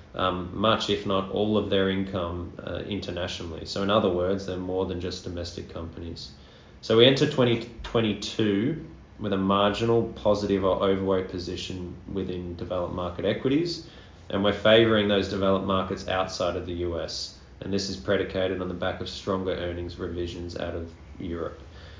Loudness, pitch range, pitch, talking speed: -26 LUFS, 90-100 Hz, 95 Hz, 160 wpm